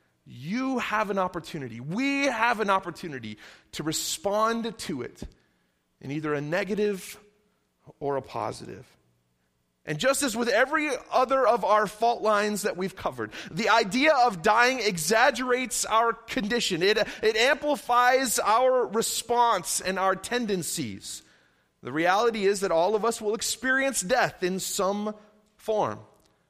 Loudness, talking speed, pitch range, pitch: -25 LUFS, 135 wpm, 175-240 Hz, 210 Hz